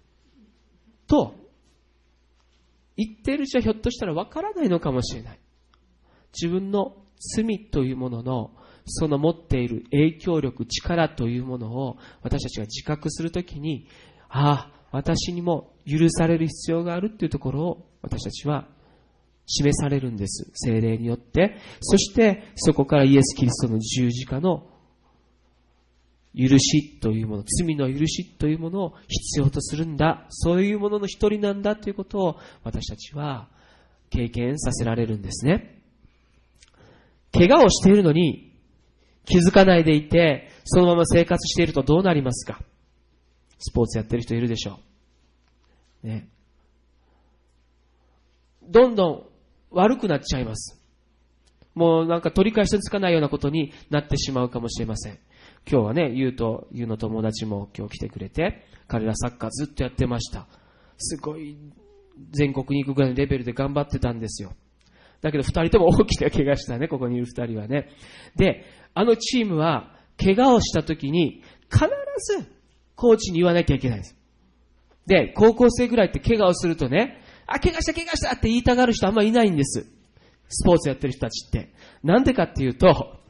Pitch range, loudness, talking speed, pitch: 110-170 Hz, -22 LUFS, 330 characters per minute, 140 Hz